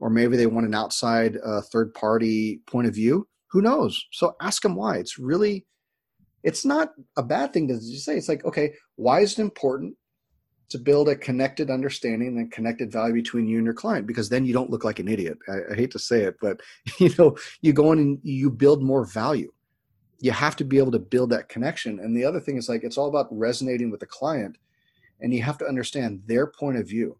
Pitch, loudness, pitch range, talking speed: 125 Hz, -24 LUFS, 115-145 Hz, 225 wpm